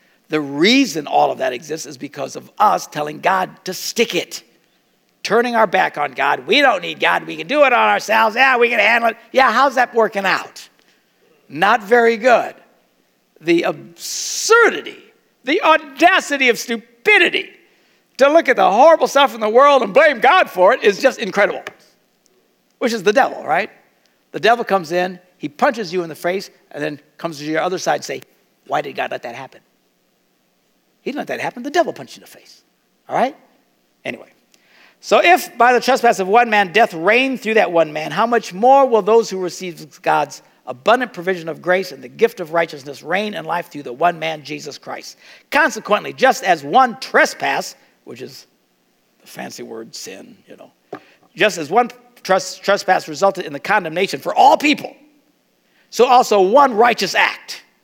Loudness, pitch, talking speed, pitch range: -16 LUFS, 230 Hz, 190 wpm, 185-265 Hz